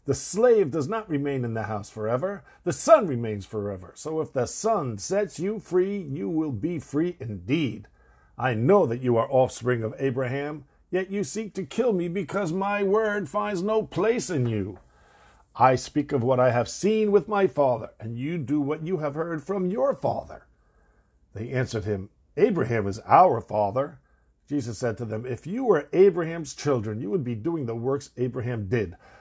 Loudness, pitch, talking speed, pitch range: -25 LUFS, 140 Hz, 185 wpm, 115-190 Hz